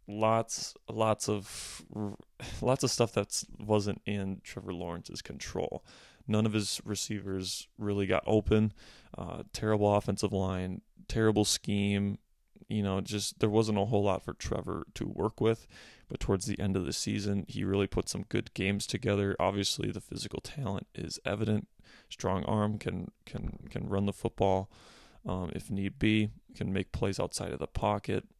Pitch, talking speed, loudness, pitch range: 100 Hz, 165 wpm, -33 LUFS, 95-110 Hz